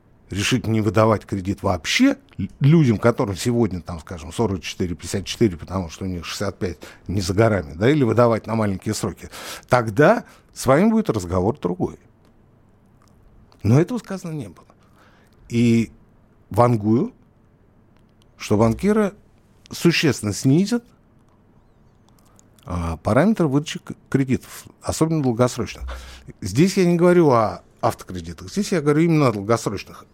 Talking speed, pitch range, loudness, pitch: 115 wpm, 100-130 Hz, -20 LUFS, 110 Hz